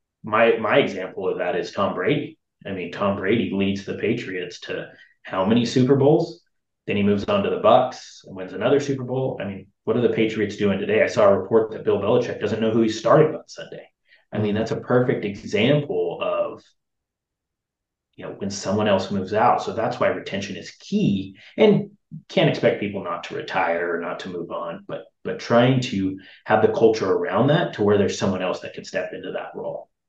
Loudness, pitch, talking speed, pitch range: -22 LUFS, 110 Hz, 210 wpm, 100-135 Hz